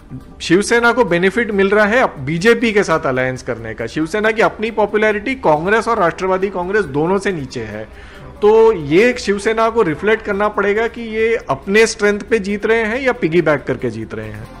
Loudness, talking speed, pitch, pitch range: -15 LUFS, 190 wpm, 205 Hz, 160-225 Hz